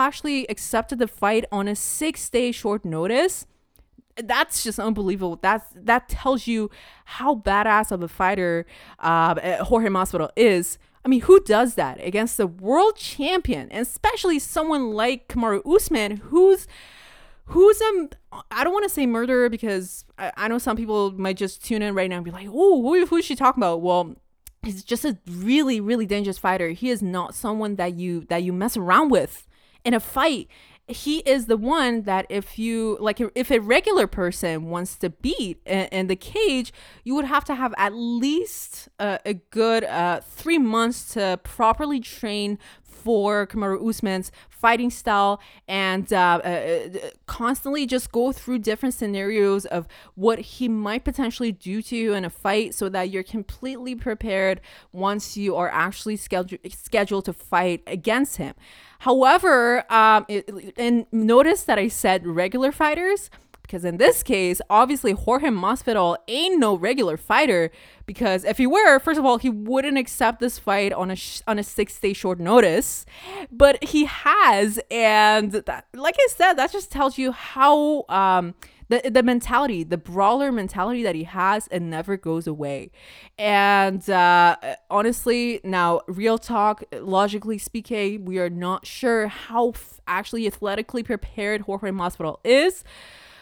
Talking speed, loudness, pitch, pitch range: 165 wpm, -21 LUFS, 220 Hz, 195-255 Hz